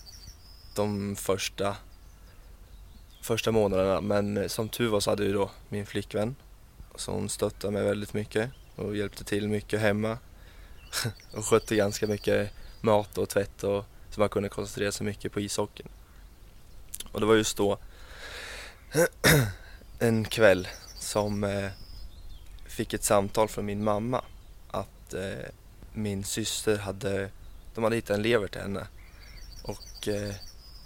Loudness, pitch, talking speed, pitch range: -29 LUFS, 100 Hz, 130 wpm, 95-105 Hz